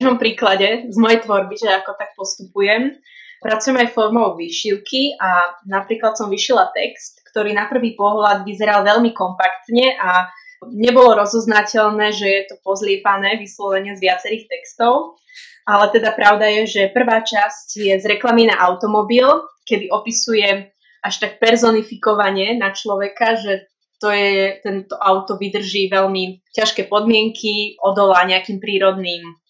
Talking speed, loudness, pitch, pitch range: 135 wpm, -16 LUFS, 210 Hz, 195-225 Hz